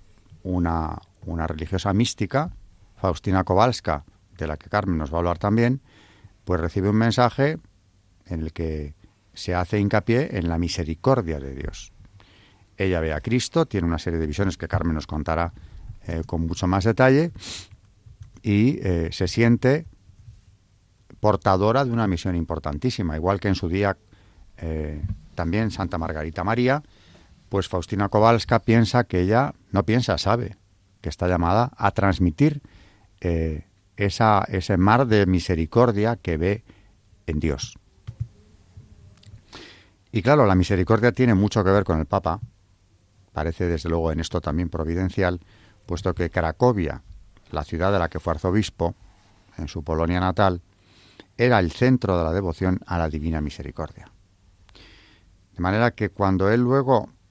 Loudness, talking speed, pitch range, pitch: -23 LUFS, 145 wpm, 85-105 Hz, 95 Hz